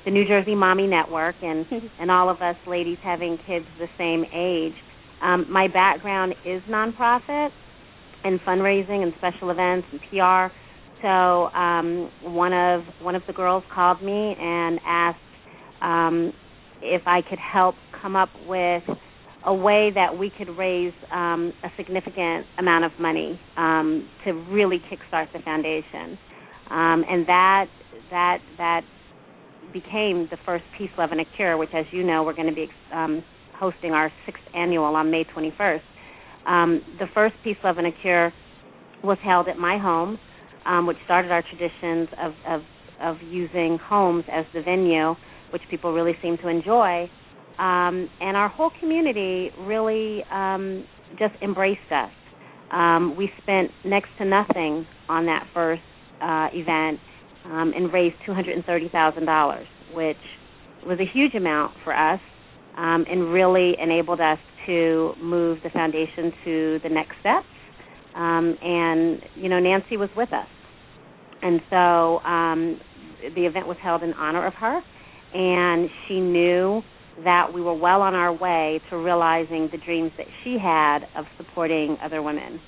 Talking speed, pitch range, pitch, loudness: 155 wpm, 165-185 Hz, 175 Hz, -23 LUFS